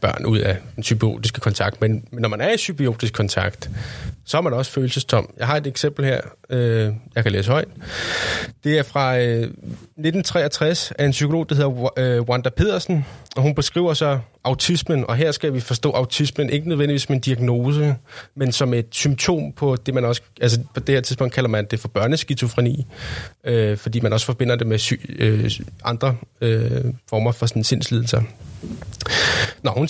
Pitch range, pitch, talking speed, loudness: 115-145 Hz, 125 Hz, 185 wpm, -21 LUFS